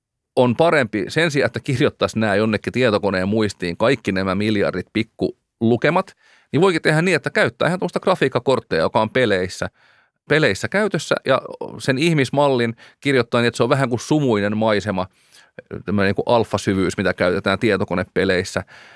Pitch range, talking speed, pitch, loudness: 100-130 Hz, 140 wpm, 115 Hz, -19 LUFS